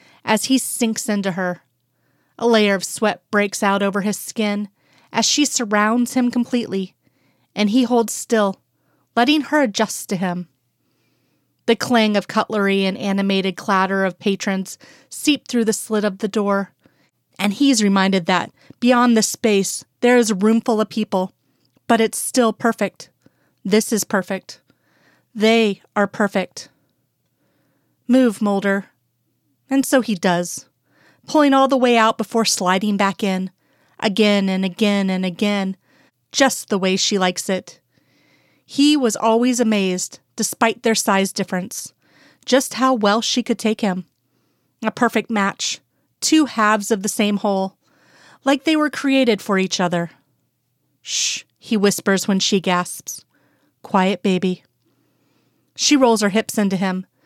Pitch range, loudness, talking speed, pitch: 185-230 Hz, -18 LUFS, 145 wpm, 205 Hz